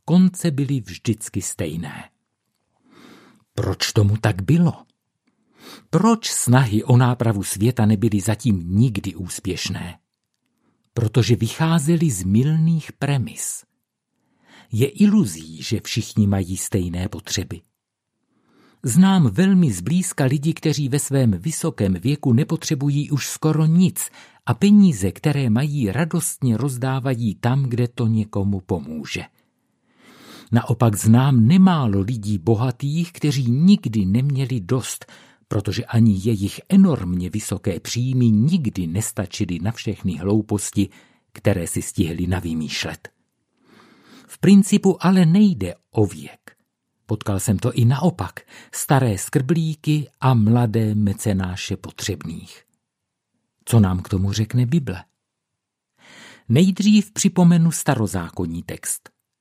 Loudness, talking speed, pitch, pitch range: -20 LUFS, 105 wpm, 120 Hz, 105-150 Hz